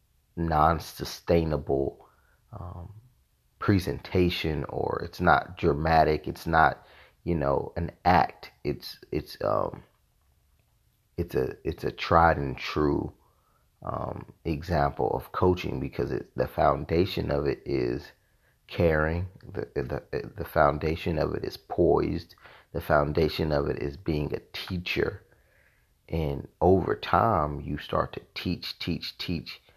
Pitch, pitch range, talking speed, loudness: 80 Hz, 75-90 Hz, 120 wpm, -28 LUFS